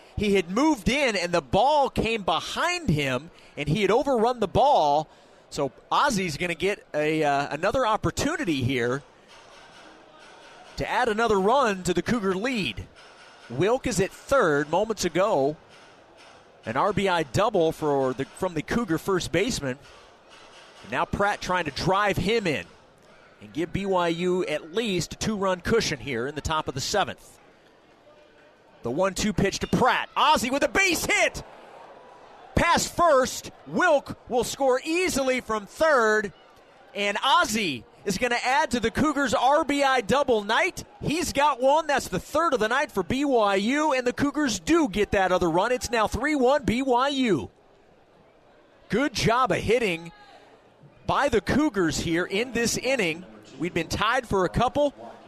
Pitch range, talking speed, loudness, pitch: 180-270 Hz, 155 wpm, -24 LUFS, 215 Hz